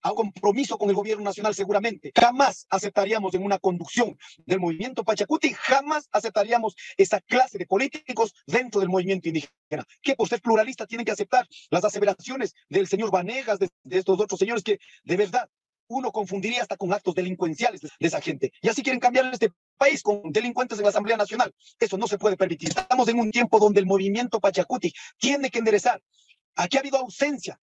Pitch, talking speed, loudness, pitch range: 215 Hz, 190 wpm, -24 LUFS, 195-250 Hz